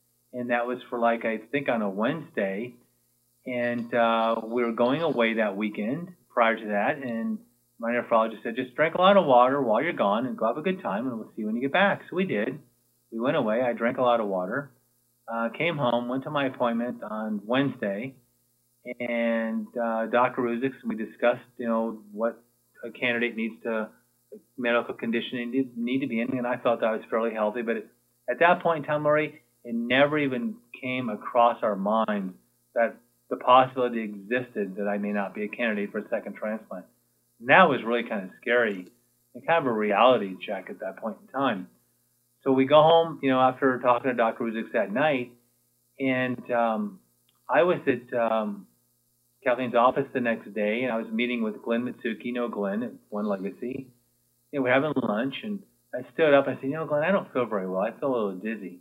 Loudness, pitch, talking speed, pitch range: -26 LUFS, 120 Hz, 210 wpm, 105-130 Hz